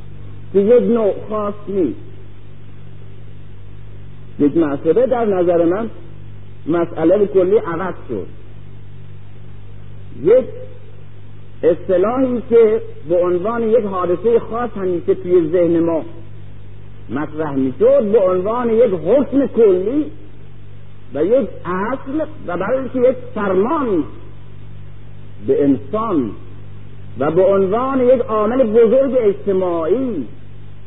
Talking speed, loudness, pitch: 95 wpm, -16 LUFS, 155 Hz